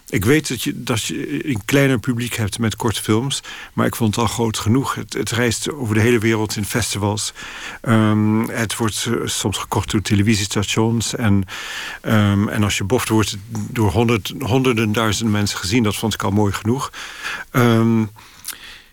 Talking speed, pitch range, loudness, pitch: 180 wpm, 105-120 Hz, -19 LUFS, 110 Hz